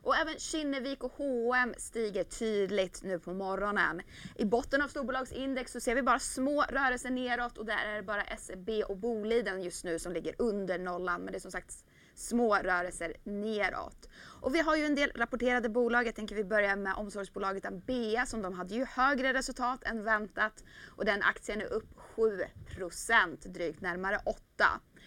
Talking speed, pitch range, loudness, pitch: 180 wpm, 200-260 Hz, -33 LUFS, 230 Hz